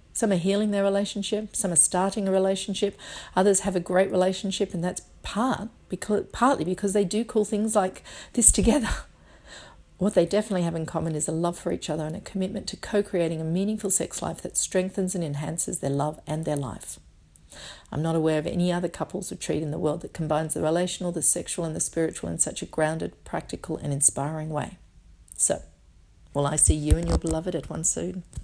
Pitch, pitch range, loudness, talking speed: 175 Hz, 155-195 Hz, -26 LUFS, 205 wpm